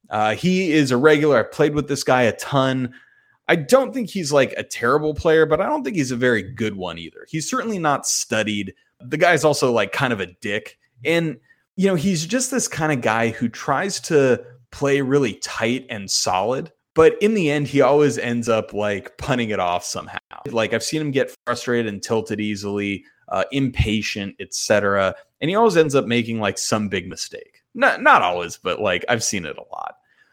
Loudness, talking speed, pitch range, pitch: -20 LUFS, 210 wpm, 110-155 Hz, 130 Hz